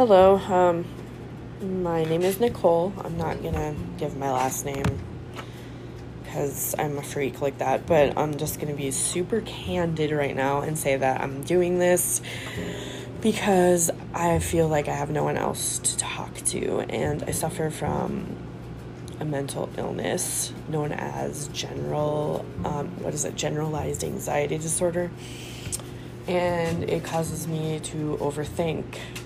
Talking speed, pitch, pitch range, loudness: 140 wpm, 150 Hz, 140-175 Hz, -26 LUFS